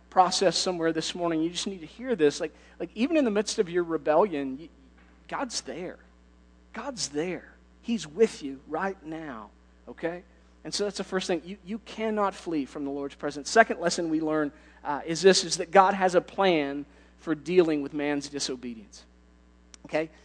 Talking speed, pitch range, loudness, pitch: 185 wpm, 140-195 Hz, -27 LUFS, 165 Hz